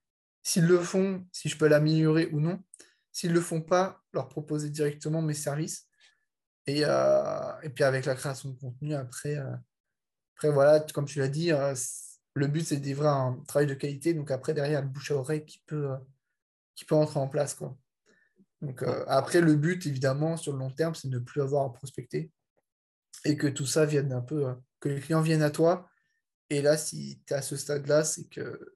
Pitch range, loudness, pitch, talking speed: 140-165 Hz, -29 LUFS, 150 Hz, 215 wpm